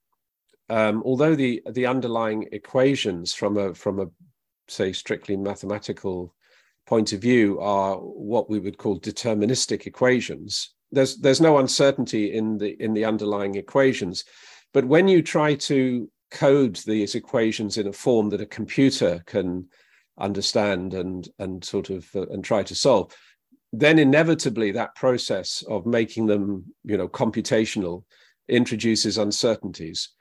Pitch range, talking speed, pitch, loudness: 100-130 Hz, 140 wpm, 110 Hz, -23 LUFS